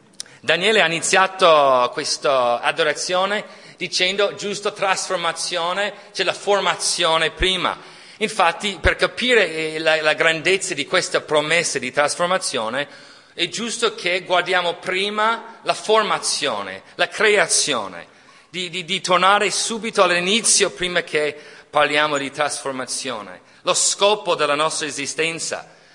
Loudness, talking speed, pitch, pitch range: -19 LUFS, 110 wpm, 175 Hz, 155-195 Hz